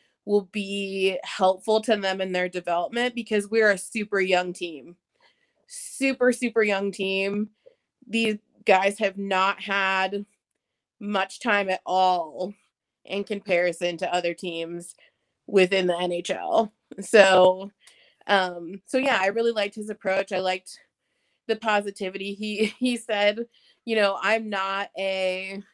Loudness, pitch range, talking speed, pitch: -24 LUFS, 185-215 Hz, 130 wpm, 200 Hz